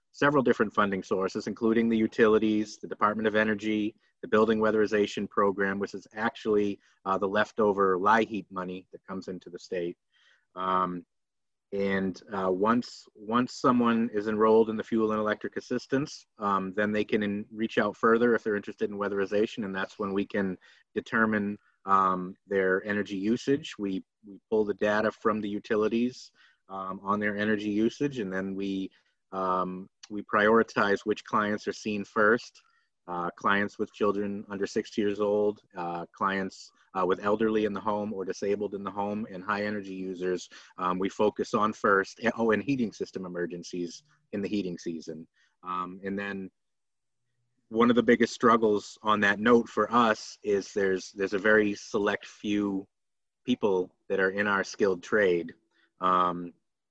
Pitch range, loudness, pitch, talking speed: 95-110 Hz, -28 LUFS, 105 Hz, 165 wpm